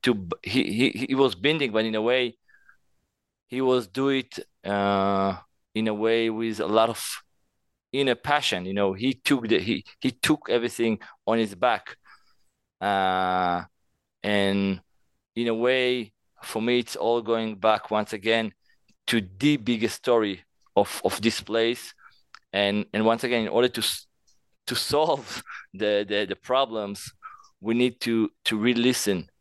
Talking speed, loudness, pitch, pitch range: 155 wpm, -25 LUFS, 115 Hz, 100-120 Hz